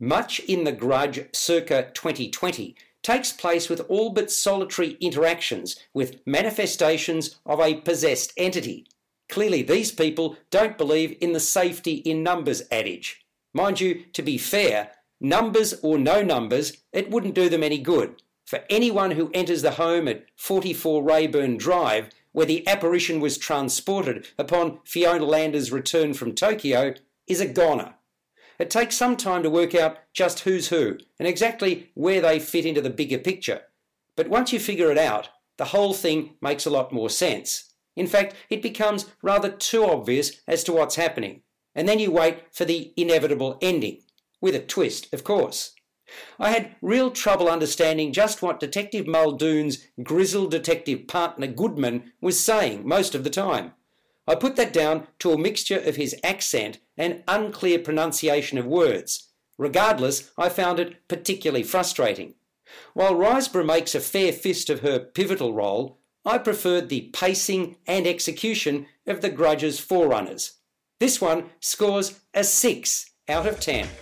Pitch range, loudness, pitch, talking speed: 155-195 Hz, -23 LUFS, 170 Hz, 155 wpm